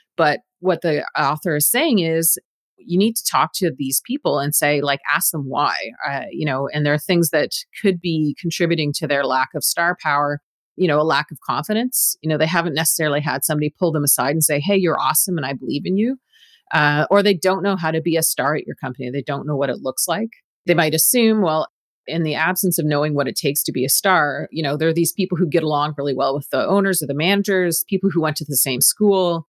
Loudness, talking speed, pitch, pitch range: -19 LUFS, 250 wpm, 160 Hz, 145-185 Hz